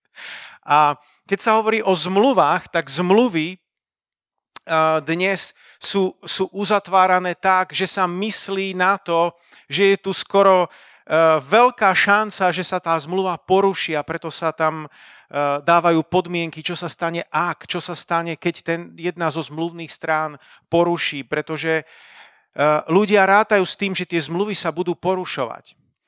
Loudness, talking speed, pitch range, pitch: -19 LUFS, 140 wpm, 160-190 Hz, 175 Hz